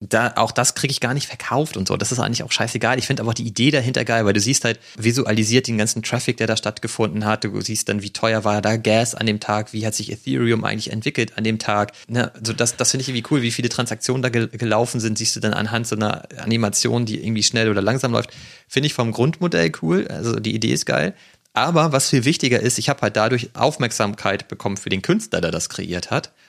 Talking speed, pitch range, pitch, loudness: 255 wpm, 110-125 Hz, 115 Hz, -20 LUFS